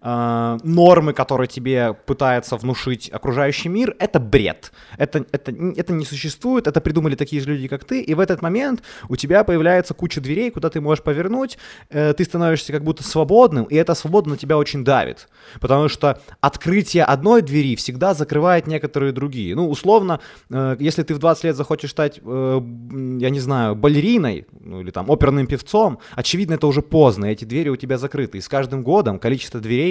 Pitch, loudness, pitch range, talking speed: 145 Hz, -19 LUFS, 130-165 Hz, 185 wpm